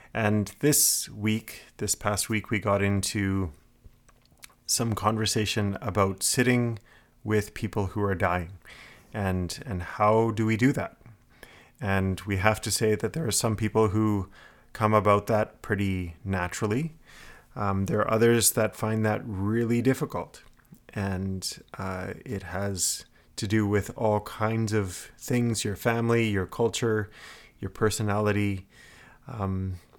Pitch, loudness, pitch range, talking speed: 105 Hz, -27 LUFS, 95-110 Hz, 135 wpm